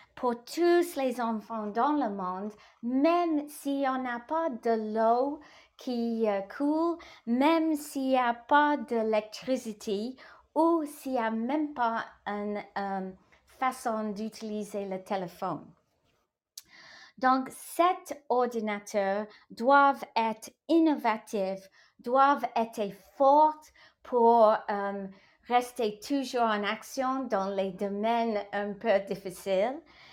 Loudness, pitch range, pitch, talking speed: -29 LUFS, 210-280 Hz, 235 Hz, 110 wpm